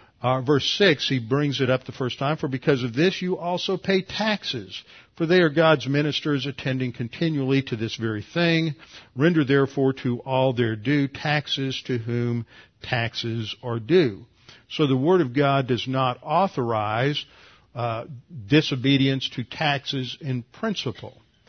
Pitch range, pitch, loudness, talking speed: 120-155 Hz, 135 Hz, -23 LUFS, 155 wpm